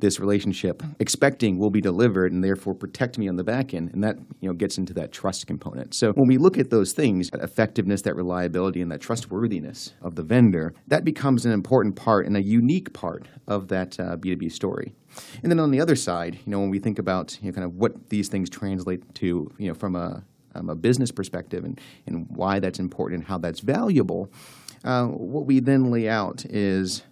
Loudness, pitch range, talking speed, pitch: -24 LUFS, 90-120 Hz, 220 wpm, 100 Hz